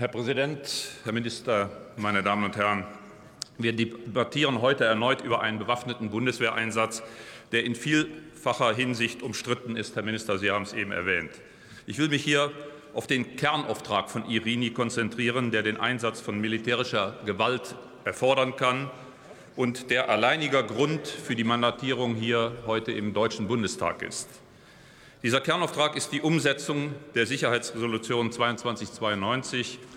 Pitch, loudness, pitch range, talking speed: 120 Hz, -27 LUFS, 110-135 Hz, 135 wpm